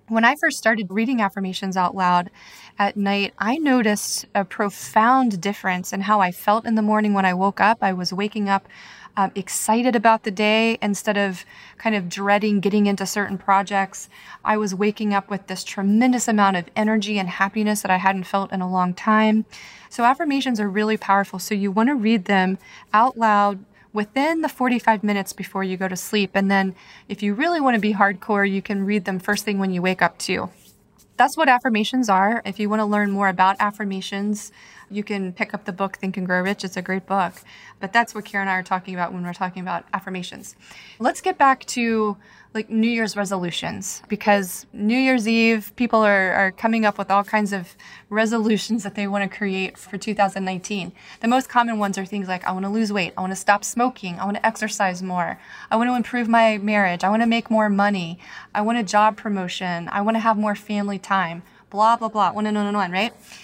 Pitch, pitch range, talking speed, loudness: 205 Hz, 195-220 Hz, 220 wpm, -21 LUFS